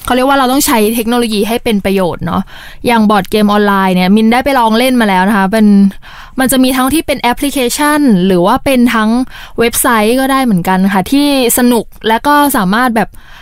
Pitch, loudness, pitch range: 235 Hz, -10 LUFS, 205-260 Hz